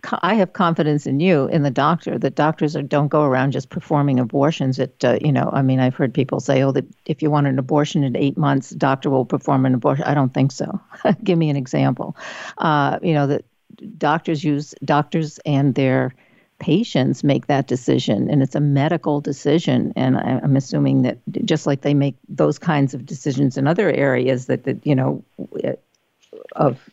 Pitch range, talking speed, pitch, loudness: 135-155 Hz, 200 wpm, 145 Hz, -19 LUFS